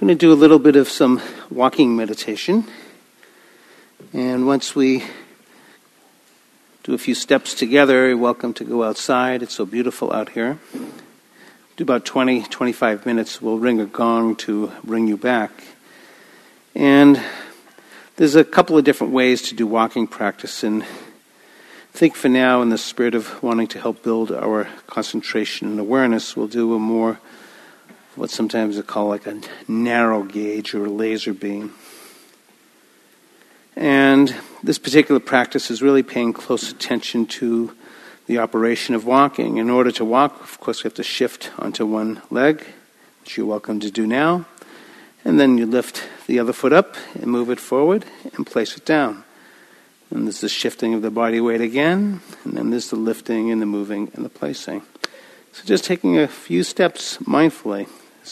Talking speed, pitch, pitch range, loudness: 165 wpm, 120 Hz, 110-130 Hz, -18 LUFS